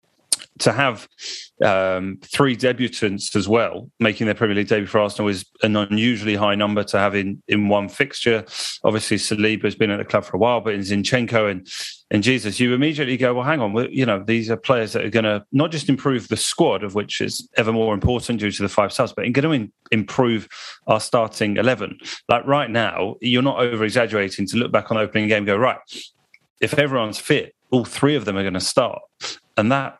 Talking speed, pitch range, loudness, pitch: 210 wpm, 105-125 Hz, -20 LUFS, 110 Hz